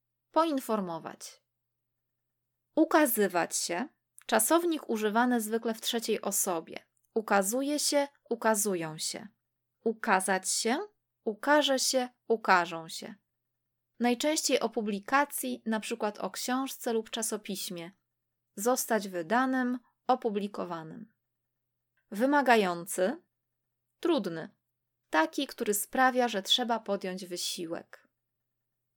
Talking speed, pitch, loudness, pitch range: 85 wpm, 210 Hz, -30 LUFS, 160-250 Hz